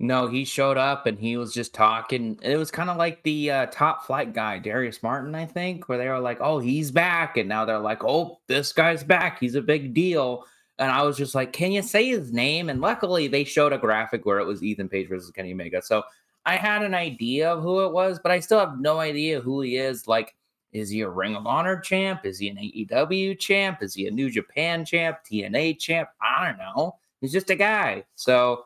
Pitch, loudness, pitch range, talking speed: 140 Hz, -24 LUFS, 120-170 Hz, 235 wpm